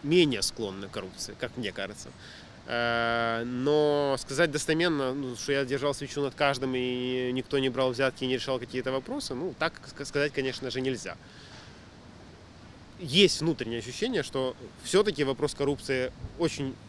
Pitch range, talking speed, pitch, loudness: 125-145 Hz, 140 wpm, 135 Hz, -29 LUFS